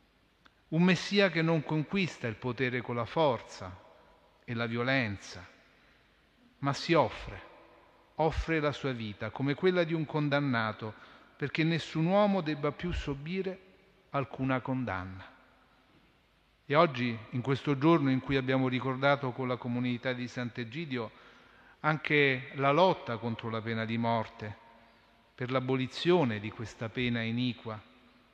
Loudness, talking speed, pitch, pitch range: -31 LUFS, 130 wpm, 130 Hz, 115-155 Hz